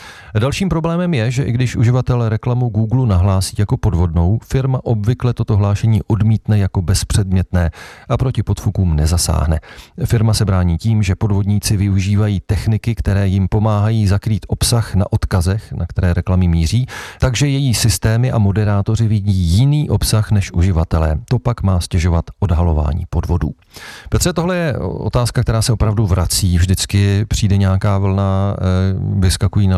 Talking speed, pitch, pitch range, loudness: 145 wpm, 105 Hz, 95-115 Hz, -16 LUFS